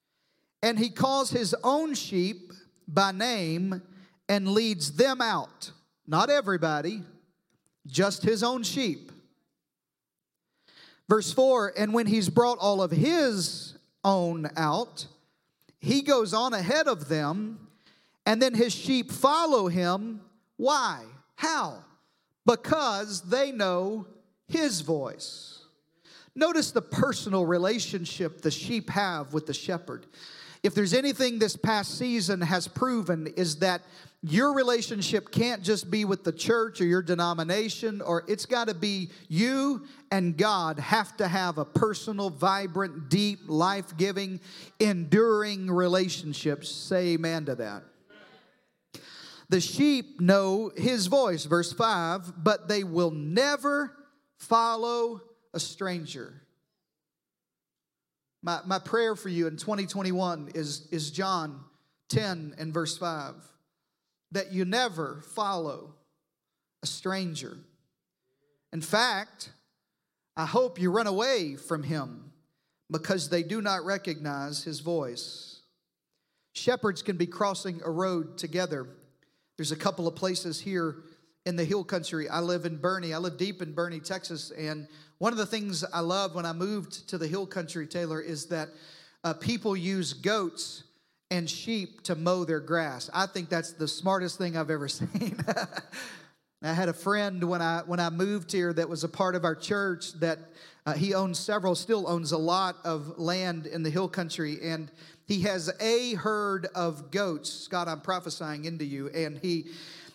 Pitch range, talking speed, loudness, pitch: 165-210 Hz, 140 wpm, -28 LUFS, 180 Hz